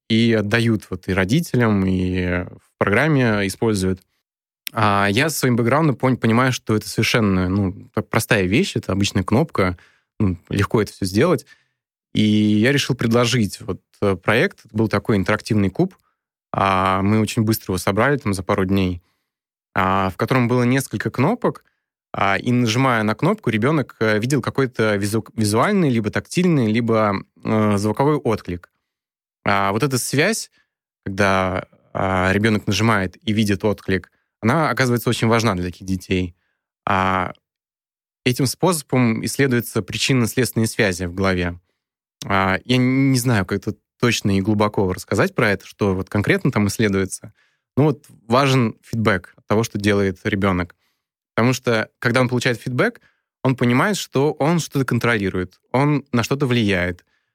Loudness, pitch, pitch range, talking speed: -19 LUFS, 110 Hz, 100-125 Hz, 140 wpm